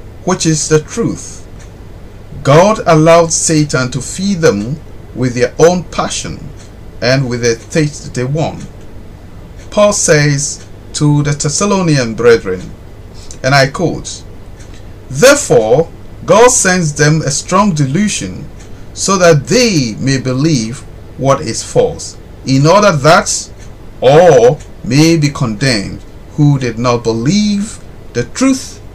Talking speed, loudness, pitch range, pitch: 120 wpm, -11 LUFS, 110-165 Hz, 140 Hz